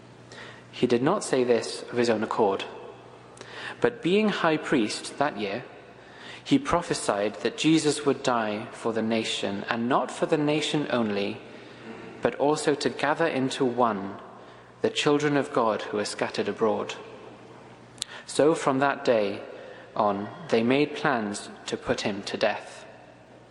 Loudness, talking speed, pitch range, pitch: -26 LUFS, 145 wpm, 110-150 Hz, 130 Hz